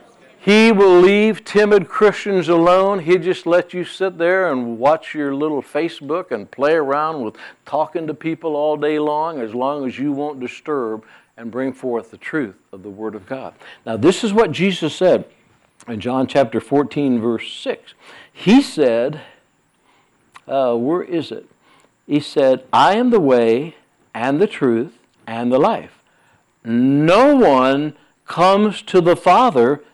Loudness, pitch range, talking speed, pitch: -17 LUFS, 130-185 Hz, 160 wpm, 150 Hz